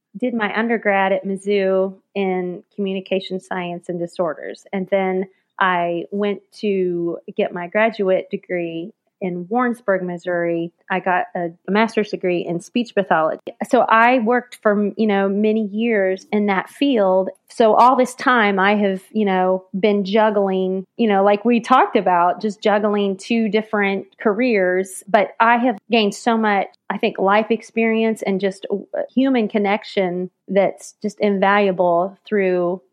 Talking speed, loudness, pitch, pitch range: 145 wpm, -19 LUFS, 200 Hz, 185-220 Hz